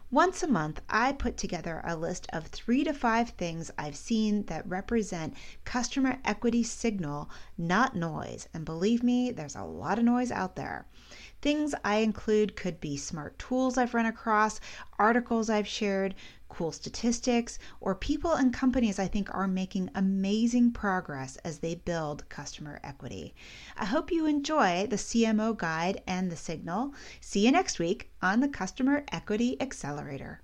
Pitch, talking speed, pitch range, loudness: 210 Hz, 160 wpm, 175-245 Hz, -30 LUFS